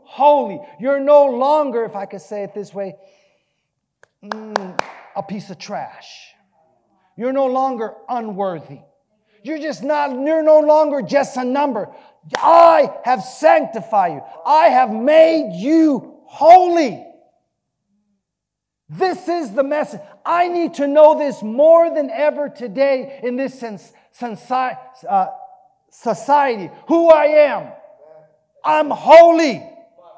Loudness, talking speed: -15 LUFS, 120 wpm